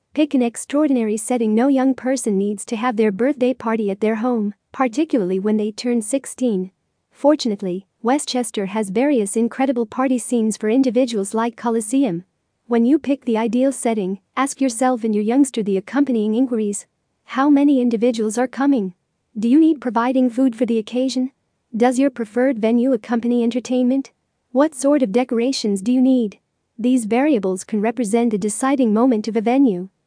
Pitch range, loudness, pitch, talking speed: 220-260 Hz, -19 LUFS, 245 Hz, 165 wpm